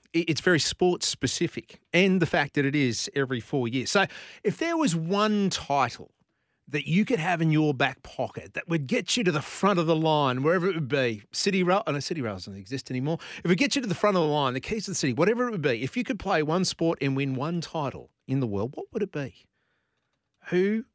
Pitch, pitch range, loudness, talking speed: 165 Hz, 140-190 Hz, -26 LUFS, 255 wpm